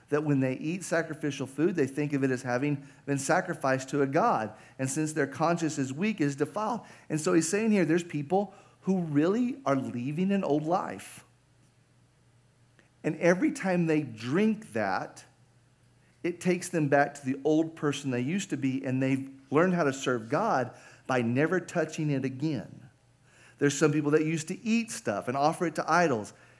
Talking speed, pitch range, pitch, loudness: 185 wpm, 130-170 Hz, 145 Hz, -29 LUFS